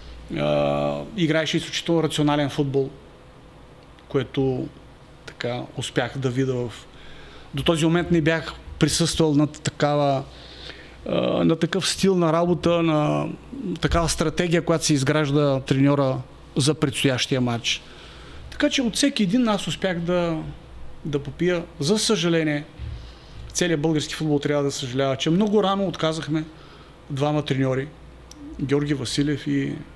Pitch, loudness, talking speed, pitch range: 150 Hz, -23 LUFS, 120 wpm, 135-165 Hz